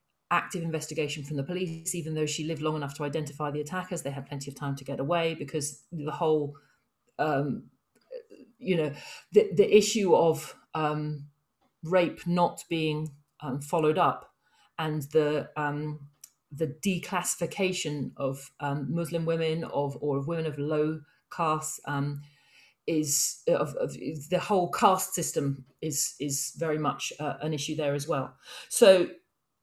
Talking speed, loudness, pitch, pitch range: 150 wpm, -29 LUFS, 155 Hz, 145-170 Hz